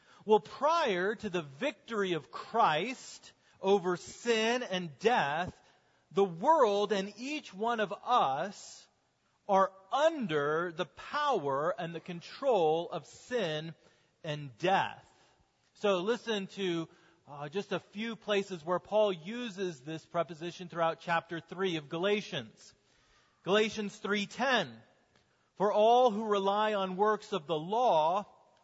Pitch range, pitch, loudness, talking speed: 170-220 Hz, 195 Hz, -32 LUFS, 120 wpm